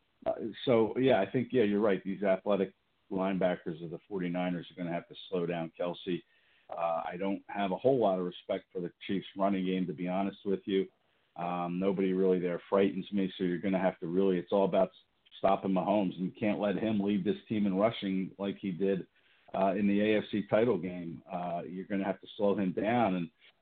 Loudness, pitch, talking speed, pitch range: -32 LUFS, 95 Hz, 225 wpm, 90-100 Hz